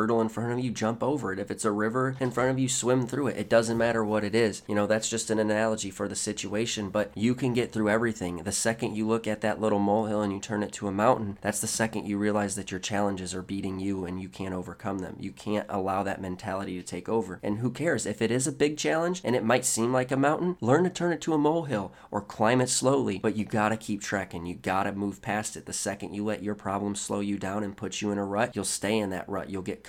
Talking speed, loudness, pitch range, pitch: 275 wpm, -28 LUFS, 100-115 Hz, 105 Hz